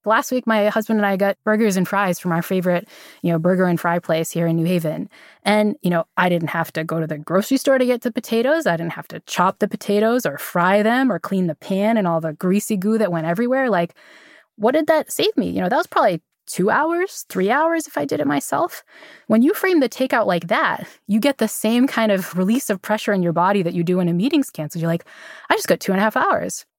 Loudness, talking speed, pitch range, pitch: -19 LUFS, 260 wpm, 175-245 Hz, 205 Hz